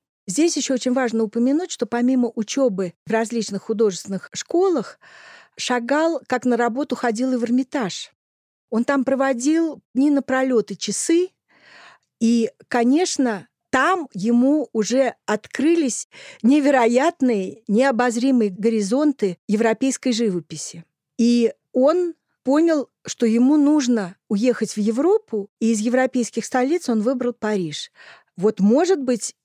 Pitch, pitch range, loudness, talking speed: 245 Hz, 225-275 Hz, -20 LUFS, 115 wpm